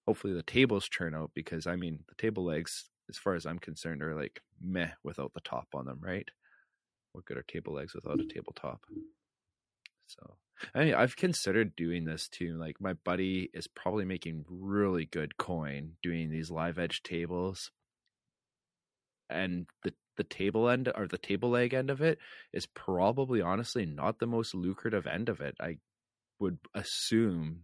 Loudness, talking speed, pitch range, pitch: -34 LUFS, 180 wpm, 85-115 Hz, 90 Hz